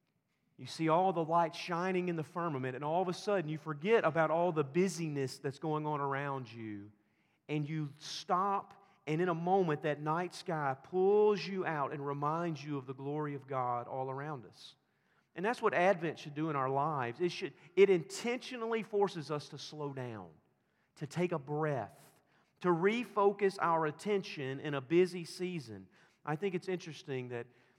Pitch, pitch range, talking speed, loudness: 155 Hz, 140-180 Hz, 180 wpm, -35 LUFS